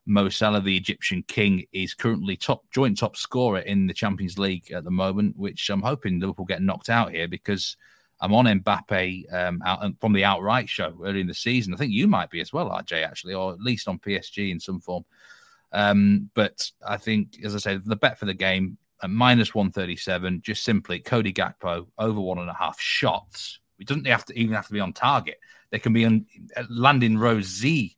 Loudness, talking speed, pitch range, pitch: -24 LUFS, 215 wpm, 95-110 Hz, 100 Hz